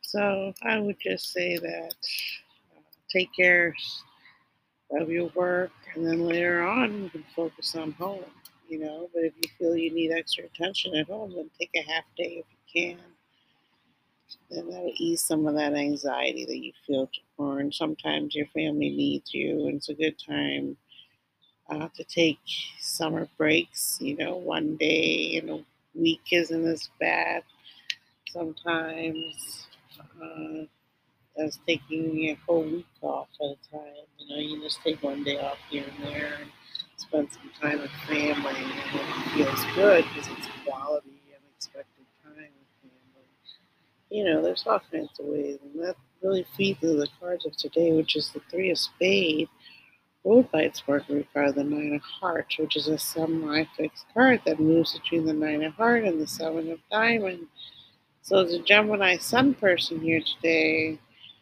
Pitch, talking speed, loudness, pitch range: 160 Hz, 170 wpm, -27 LUFS, 145-175 Hz